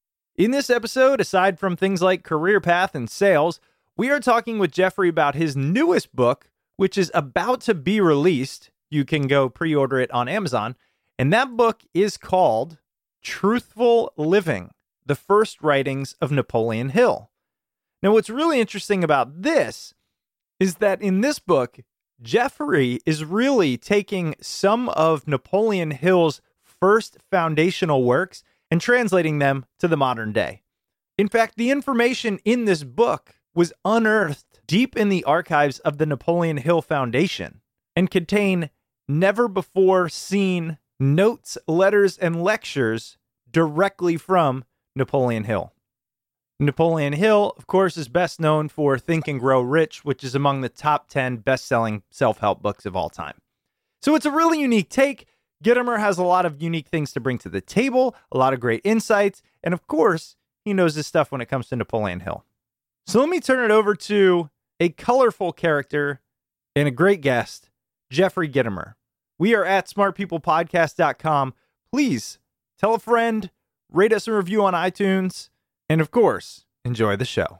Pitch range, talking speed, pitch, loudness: 135-205 Hz, 160 wpm, 170 Hz, -21 LUFS